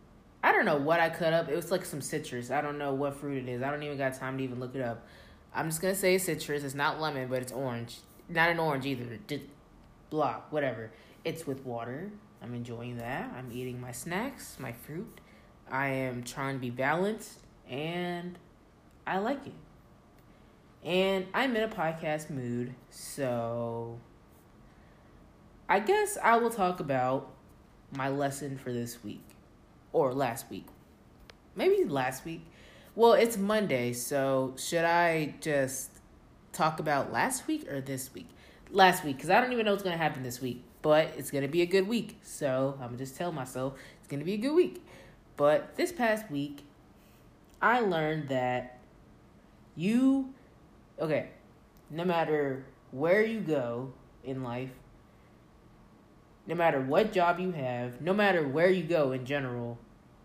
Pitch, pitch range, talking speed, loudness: 145 Hz, 130-180 Hz, 170 wpm, -31 LUFS